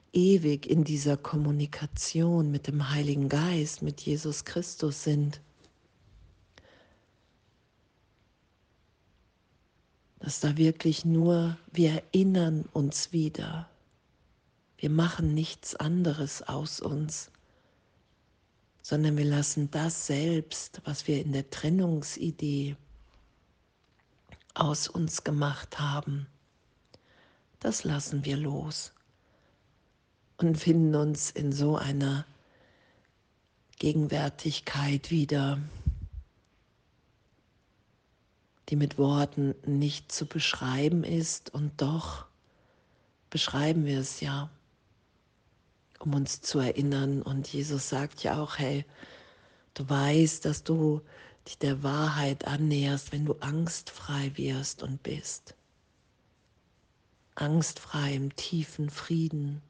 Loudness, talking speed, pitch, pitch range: -30 LUFS, 95 wpm, 145 Hz, 140-155 Hz